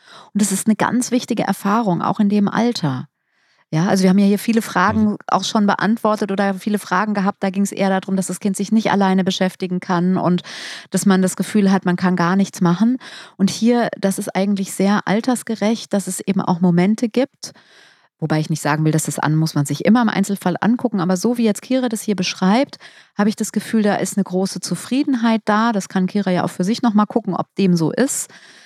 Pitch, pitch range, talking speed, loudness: 195 Hz, 185-220 Hz, 230 wpm, -18 LUFS